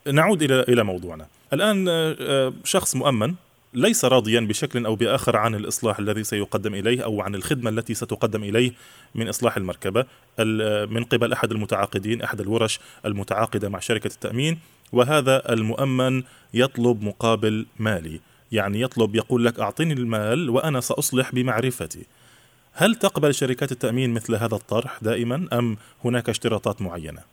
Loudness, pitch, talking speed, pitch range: -23 LUFS, 115 Hz, 135 wpm, 110-130 Hz